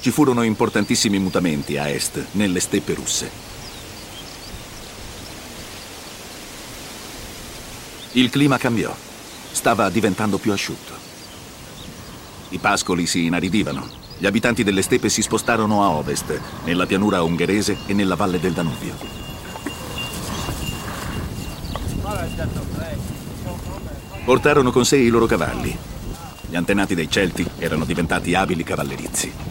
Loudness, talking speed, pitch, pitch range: -20 LUFS, 100 wpm, 100 Hz, 85-110 Hz